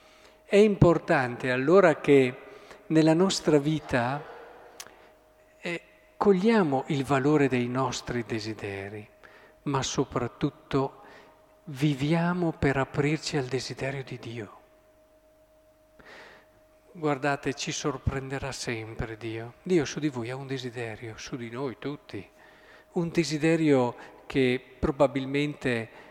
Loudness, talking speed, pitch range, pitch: -27 LUFS, 100 wpm, 125-165 Hz, 140 Hz